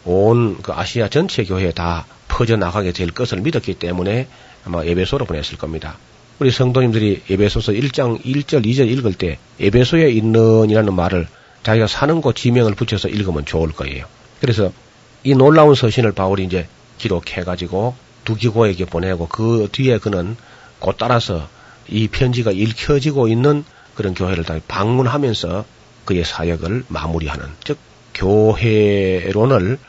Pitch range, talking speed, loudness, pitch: 90-125 Hz, 320 characters per minute, -17 LUFS, 110 Hz